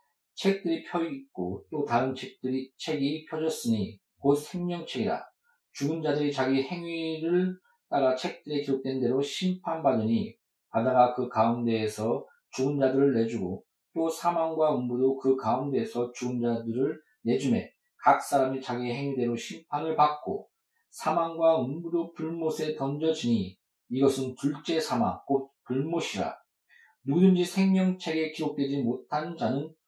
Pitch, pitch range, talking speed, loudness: 145 Hz, 130-165 Hz, 285 characters per minute, -29 LUFS